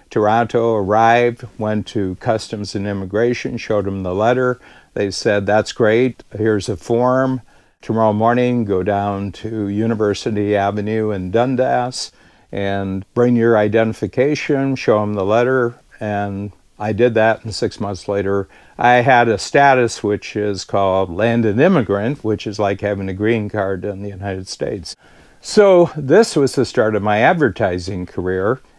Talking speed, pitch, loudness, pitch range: 150 wpm, 110 Hz, -17 LUFS, 100-120 Hz